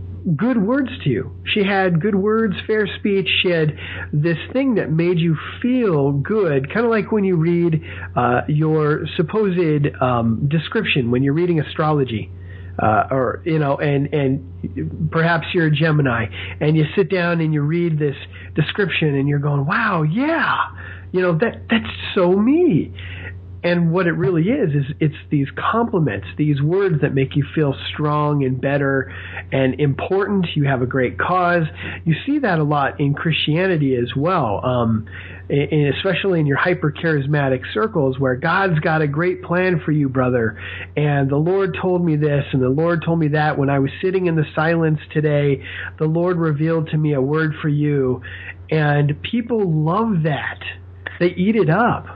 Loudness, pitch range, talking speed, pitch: -19 LUFS, 135-175 Hz, 175 wpm, 155 Hz